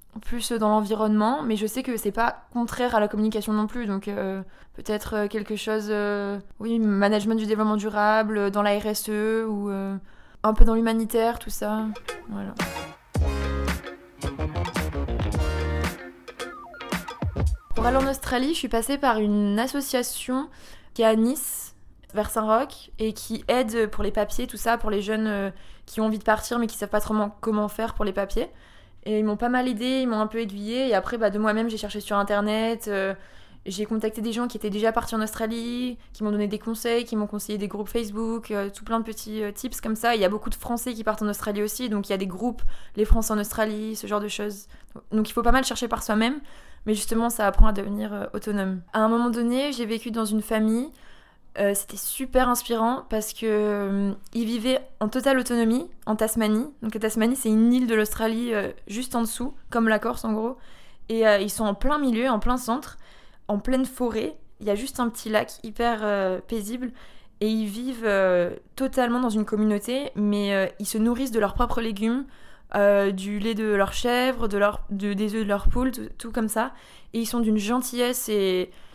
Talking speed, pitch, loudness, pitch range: 210 wpm, 220 Hz, -25 LUFS, 210-235 Hz